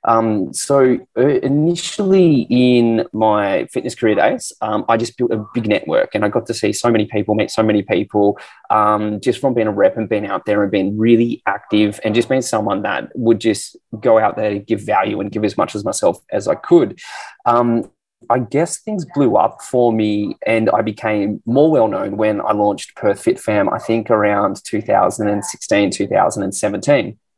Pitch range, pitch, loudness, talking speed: 105-120 Hz, 115 Hz, -16 LUFS, 195 wpm